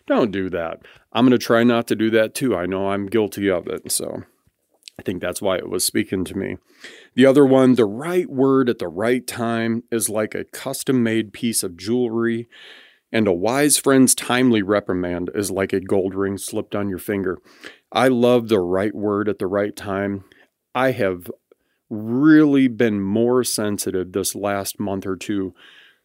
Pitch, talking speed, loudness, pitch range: 110 Hz, 185 wpm, -20 LUFS, 100-125 Hz